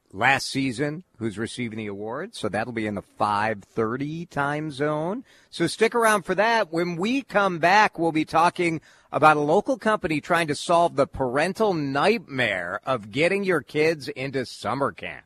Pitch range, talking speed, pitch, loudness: 130-175 Hz, 170 wpm, 155 Hz, -24 LUFS